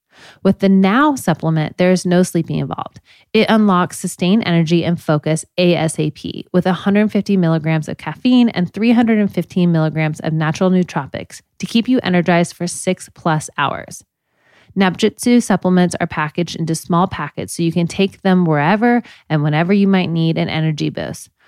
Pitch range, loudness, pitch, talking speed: 160-195 Hz, -16 LUFS, 175 Hz, 155 wpm